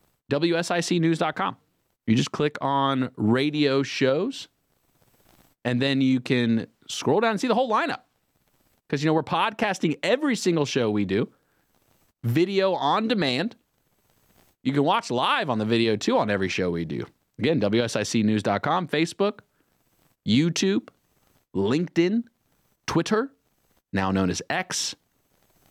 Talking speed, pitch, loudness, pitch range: 125 wpm, 140 Hz, -24 LUFS, 115-170 Hz